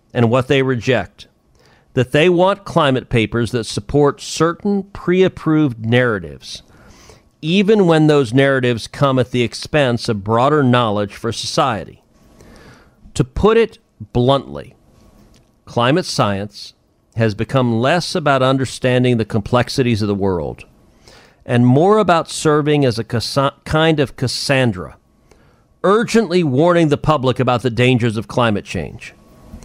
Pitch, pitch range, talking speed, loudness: 130 Hz, 115-155 Hz, 130 wpm, -16 LUFS